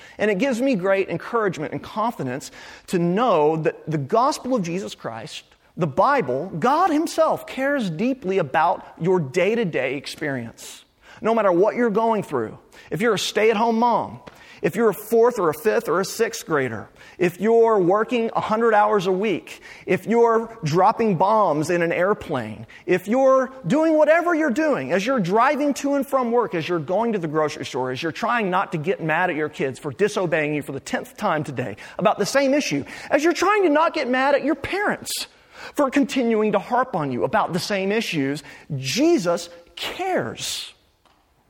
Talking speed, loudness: 190 wpm, -21 LUFS